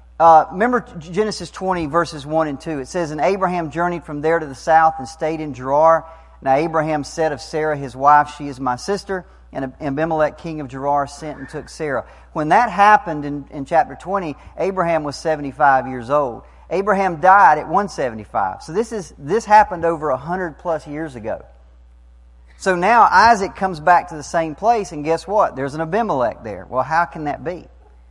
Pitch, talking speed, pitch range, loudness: 160 Hz, 190 wpm, 140-175 Hz, -18 LUFS